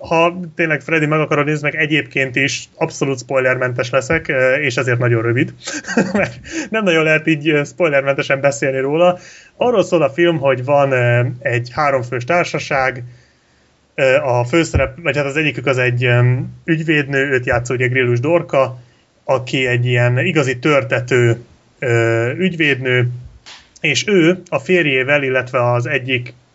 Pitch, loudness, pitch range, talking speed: 140 Hz, -16 LUFS, 125-160 Hz, 135 wpm